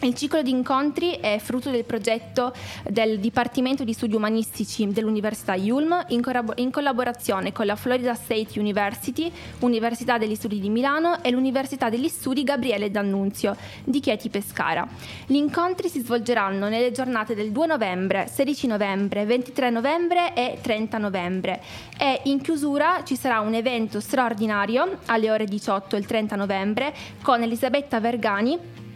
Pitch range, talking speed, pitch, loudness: 215-270 Hz, 145 wpm, 240 Hz, -24 LUFS